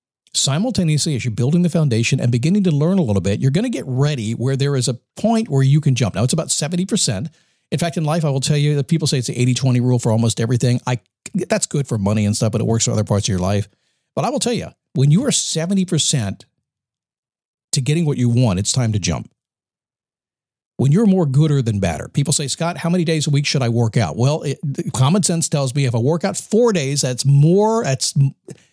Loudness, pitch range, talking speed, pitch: -18 LUFS, 125-165 Hz, 245 wpm, 140 Hz